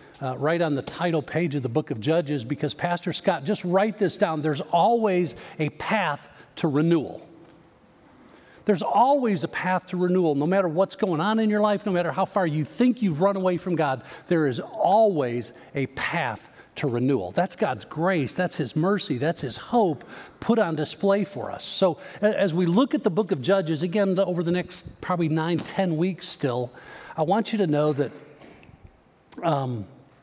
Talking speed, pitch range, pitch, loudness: 190 wpm, 150-195 Hz, 175 Hz, -24 LUFS